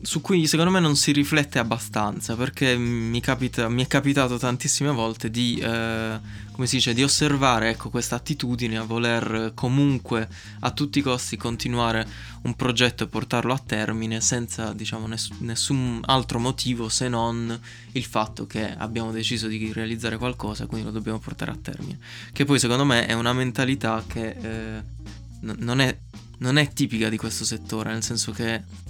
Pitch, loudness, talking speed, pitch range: 115 Hz, -24 LUFS, 170 wpm, 110-130 Hz